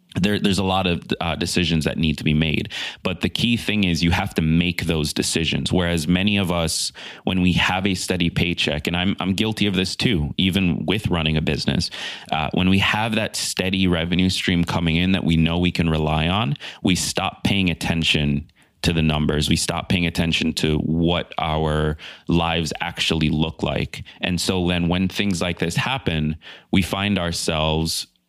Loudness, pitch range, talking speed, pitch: -21 LUFS, 80-95 Hz, 195 wpm, 85 Hz